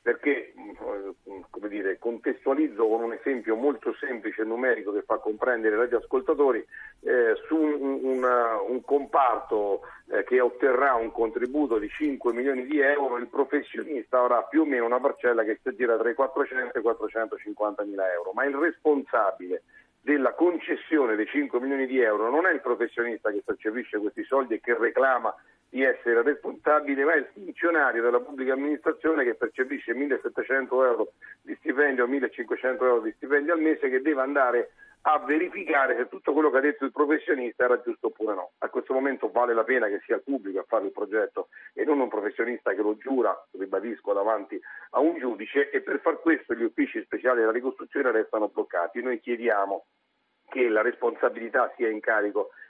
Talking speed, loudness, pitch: 180 wpm, -26 LUFS, 150 Hz